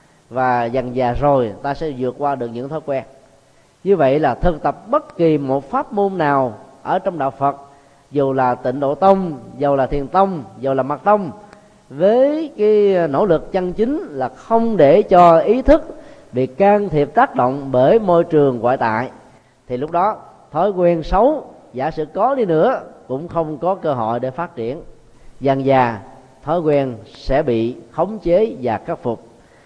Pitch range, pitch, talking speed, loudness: 130-190 Hz, 145 Hz, 185 wpm, -17 LUFS